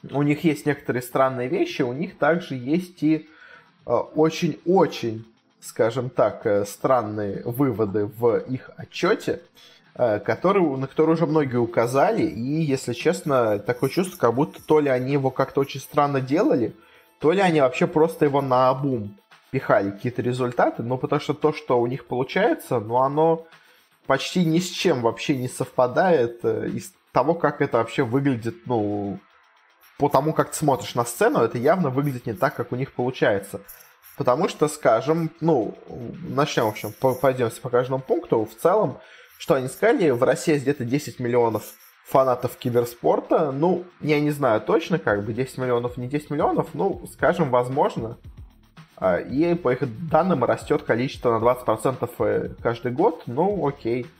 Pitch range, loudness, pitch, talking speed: 120-155 Hz, -23 LUFS, 135 Hz, 165 wpm